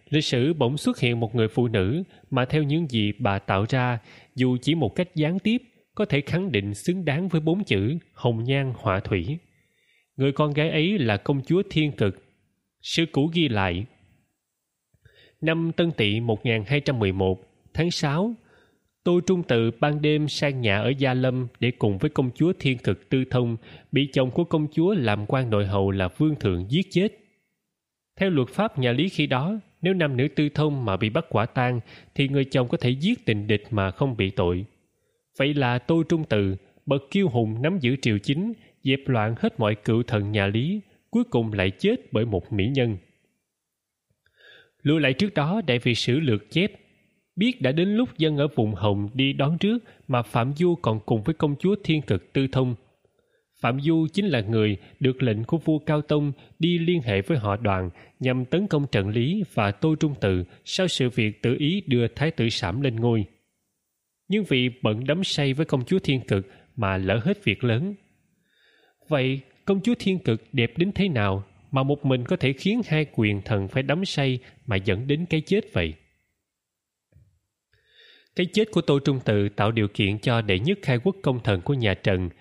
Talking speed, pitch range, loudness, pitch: 200 wpm, 110-160 Hz, -24 LUFS, 135 Hz